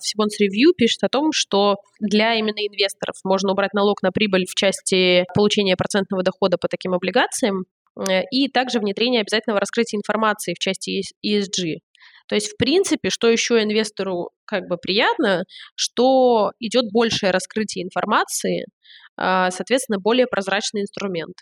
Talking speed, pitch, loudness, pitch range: 145 wpm, 205 Hz, -20 LUFS, 190-225 Hz